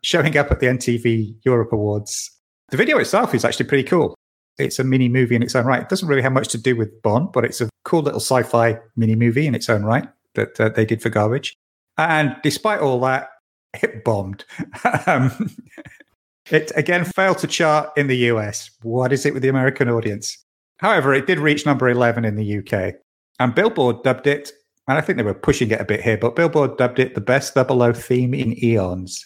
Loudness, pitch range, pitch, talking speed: -19 LUFS, 115-145 Hz, 125 Hz, 215 wpm